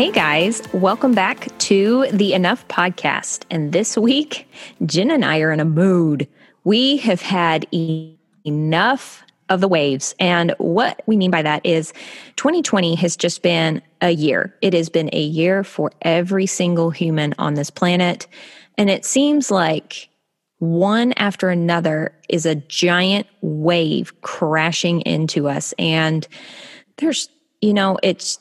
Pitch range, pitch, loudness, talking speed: 160-200 Hz, 175 Hz, -18 LUFS, 150 wpm